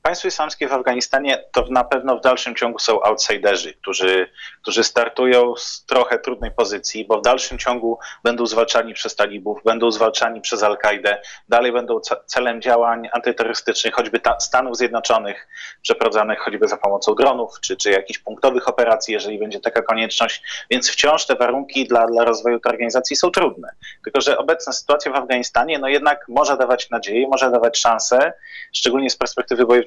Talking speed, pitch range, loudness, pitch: 165 wpm, 115-135 Hz, -18 LUFS, 120 Hz